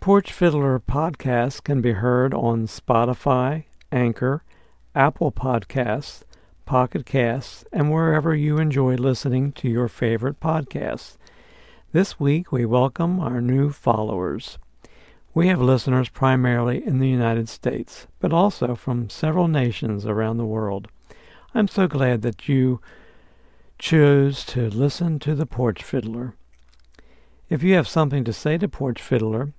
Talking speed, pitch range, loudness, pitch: 135 wpm, 120-150 Hz, -22 LUFS, 130 Hz